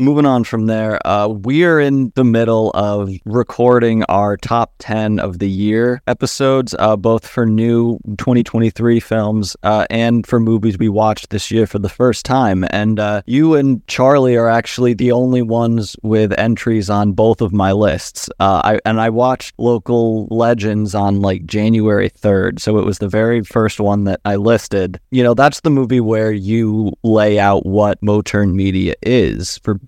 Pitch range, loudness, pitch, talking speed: 105-120 Hz, -14 LUFS, 110 Hz, 180 wpm